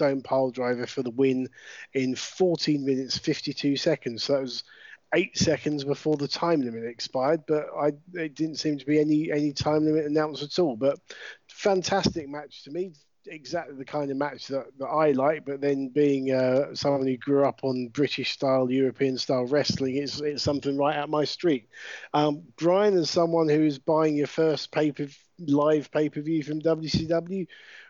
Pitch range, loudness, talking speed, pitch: 135-155 Hz, -26 LUFS, 185 wpm, 145 Hz